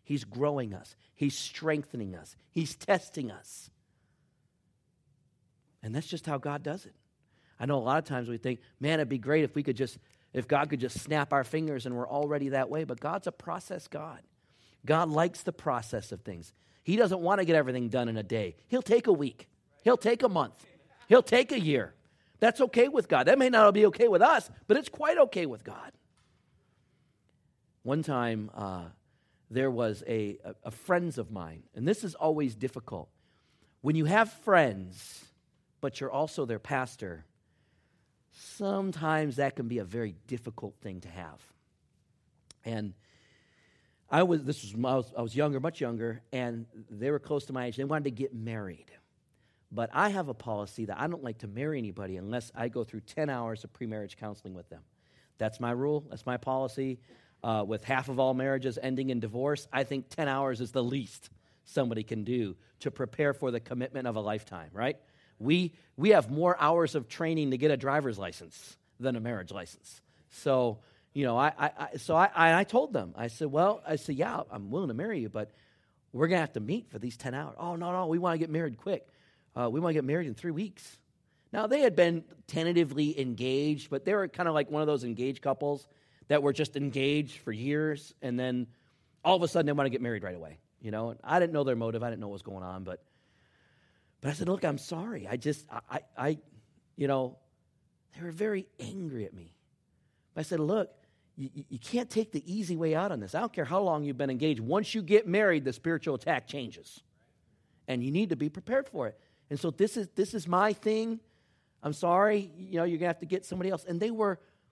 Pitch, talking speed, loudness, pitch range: 140 Hz, 210 wpm, -31 LUFS, 120-165 Hz